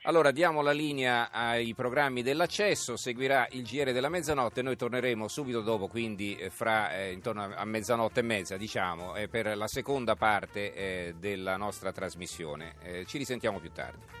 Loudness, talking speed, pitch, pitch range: -31 LUFS, 170 wpm, 115 Hz, 100-125 Hz